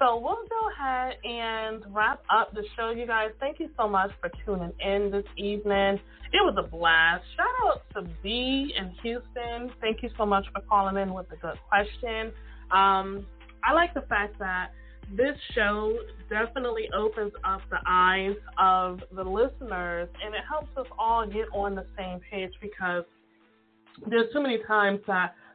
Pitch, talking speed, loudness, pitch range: 210 Hz, 170 wpm, -27 LUFS, 190-240 Hz